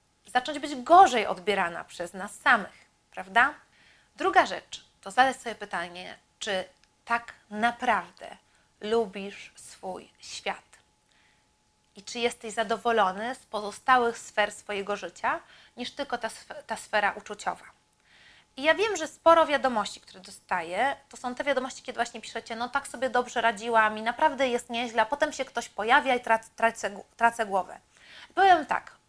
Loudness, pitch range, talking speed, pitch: -27 LUFS, 210-265 Hz, 145 wpm, 235 Hz